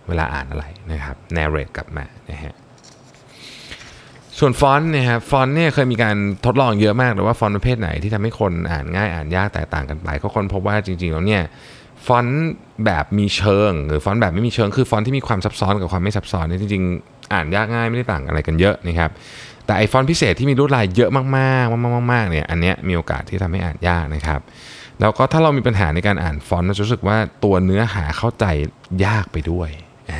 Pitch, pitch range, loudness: 105 Hz, 85-125 Hz, -18 LUFS